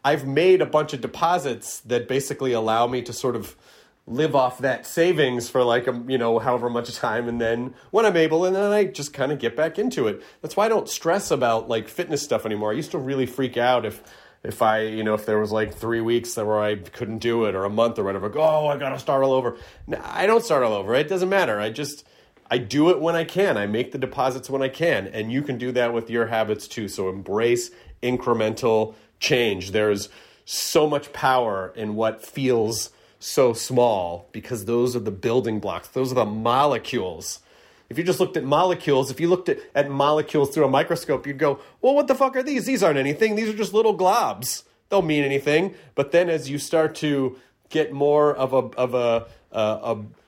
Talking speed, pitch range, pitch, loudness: 230 wpm, 115-150 Hz, 130 Hz, -23 LUFS